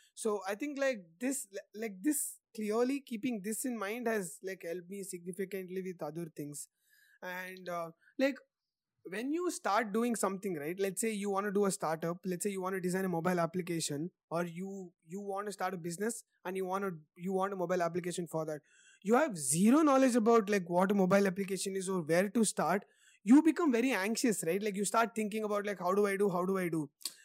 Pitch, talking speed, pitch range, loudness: 195 Hz, 220 wpm, 180-225 Hz, -34 LUFS